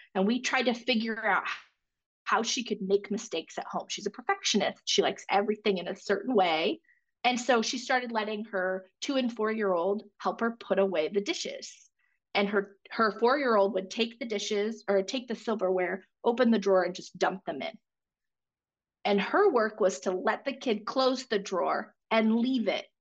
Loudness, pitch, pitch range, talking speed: -29 LUFS, 220 Hz, 195-245 Hz, 200 wpm